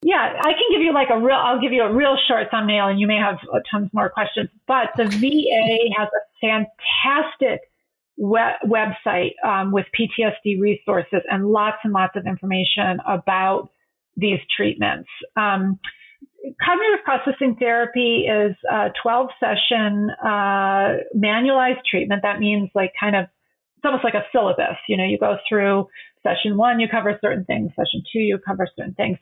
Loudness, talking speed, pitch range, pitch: -20 LUFS, 165 wpm, 200-250 Hz, 215 Hz